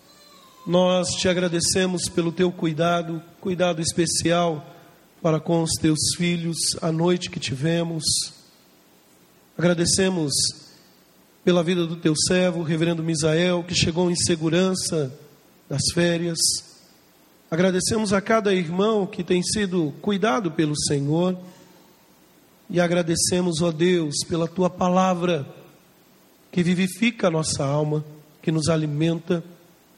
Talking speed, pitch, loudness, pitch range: 110 wpm, 170 Hz, -22 LUFS, 165-180 Hz